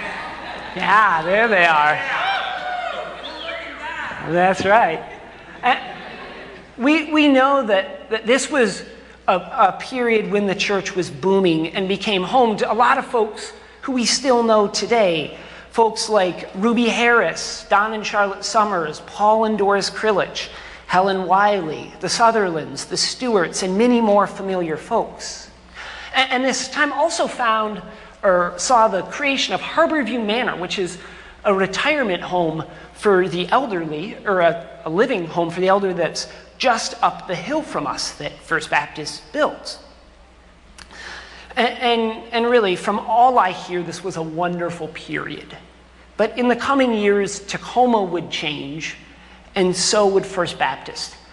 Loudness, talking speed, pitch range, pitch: -19 LUFS, 145 wpm, 180-235 Hz, 205 Hz